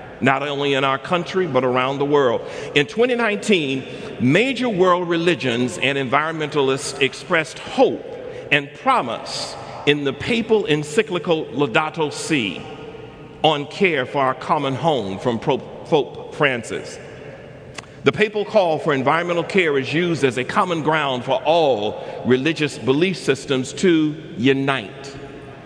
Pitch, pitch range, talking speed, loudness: 150 Hz, 135-185 Hz, 130 wpm, -20 LUFS